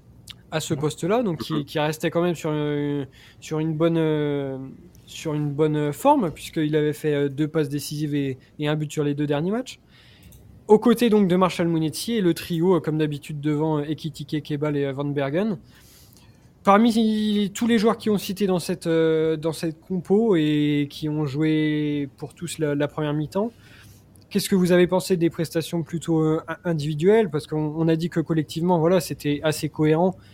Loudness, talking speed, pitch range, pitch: -23 LUFS, 180 wpm, 150-180 Hz, 155 Hz